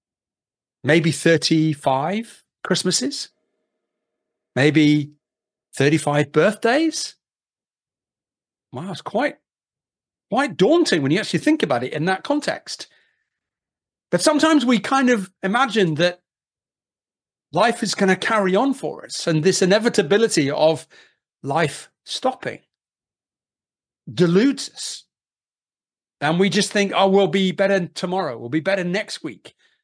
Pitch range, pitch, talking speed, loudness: 160-230 Hz, 195 Hz, 115 wpm, -19 LUFS